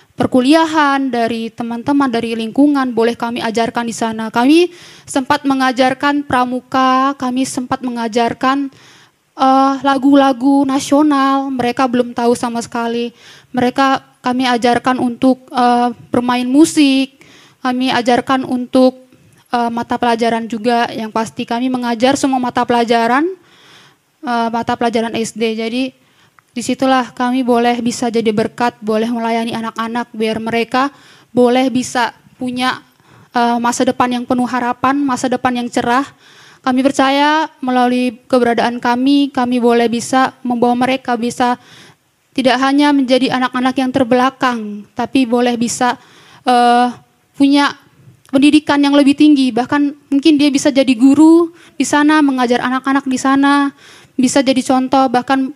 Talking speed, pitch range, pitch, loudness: 125 wpm, 240-270 Hz, 255 Hz, -14 LUFS